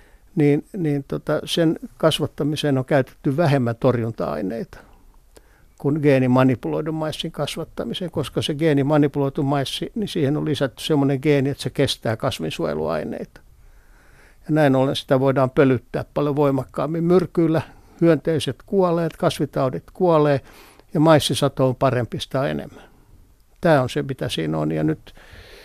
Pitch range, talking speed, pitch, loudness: 130-160 Hz, 125 wpm, 145 Hz, -21 LUFS